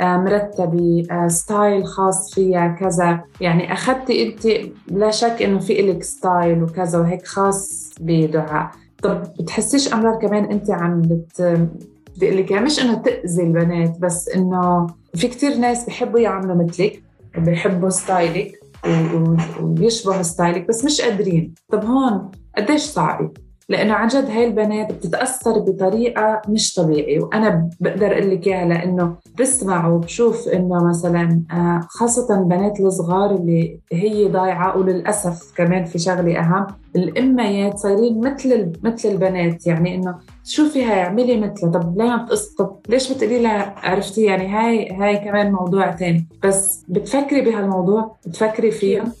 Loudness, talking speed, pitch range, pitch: -18 LUFS, 135 wpm, 175-220 Hz, 195 Hz